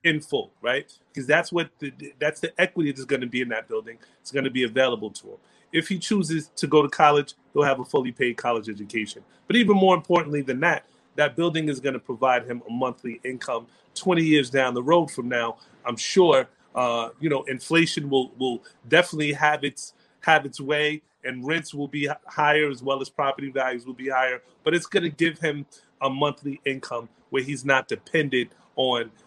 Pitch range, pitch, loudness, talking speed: 130-155 Hz, 145 Hz, -24 LUFS, 210 wpm